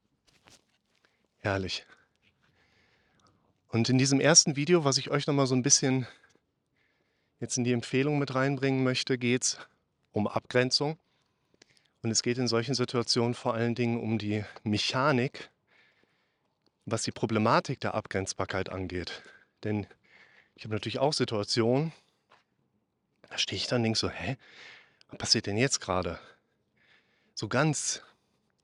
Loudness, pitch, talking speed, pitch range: -28 LUFS, 120 Hz, 130 wpm, 110-135 Hz